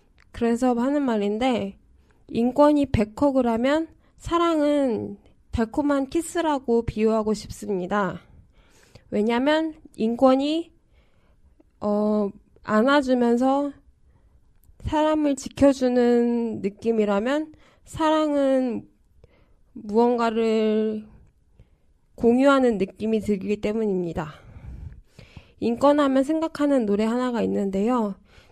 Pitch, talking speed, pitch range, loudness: 235 Hz, 205 characters per minute, 210-280 Hz, -23 LUFS